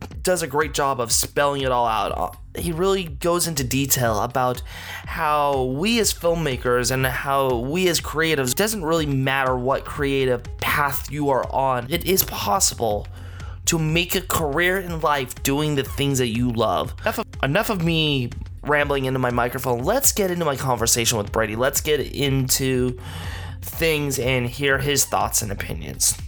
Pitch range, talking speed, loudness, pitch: 120-150 Hz, 170 wpm, -21 LUFS, 135 Hz